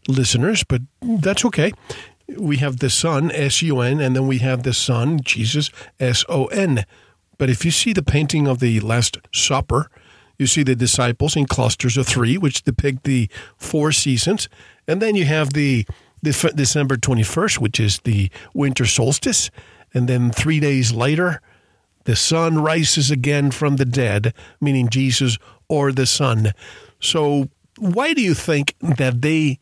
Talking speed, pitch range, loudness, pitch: 165 wpm, 125-150 Hz, -18 LUFS, 135 Hz